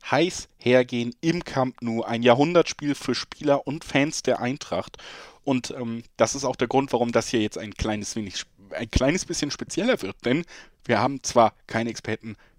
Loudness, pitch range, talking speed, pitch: -25 LUFS, 115-140 Hz, 180 wpm, 125 Hz